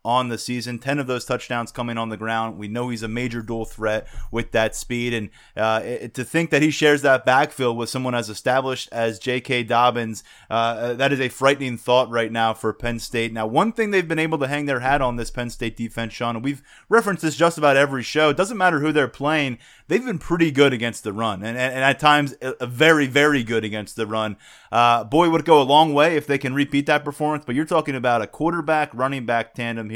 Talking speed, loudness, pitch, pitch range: 240 wpm, -21 LUFS, 125 Hz, 115-145 Hz